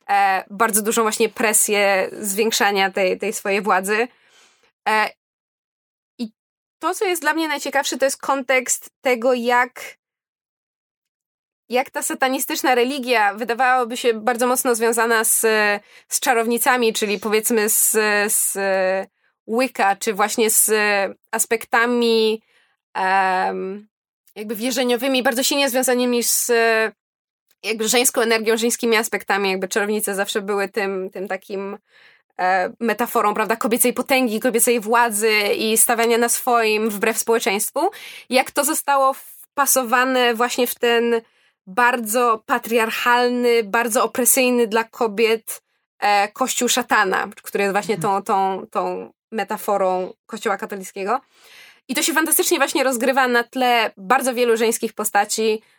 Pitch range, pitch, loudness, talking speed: 210-250 Hz, 230 Hz, -19 LUFS, 120 wpm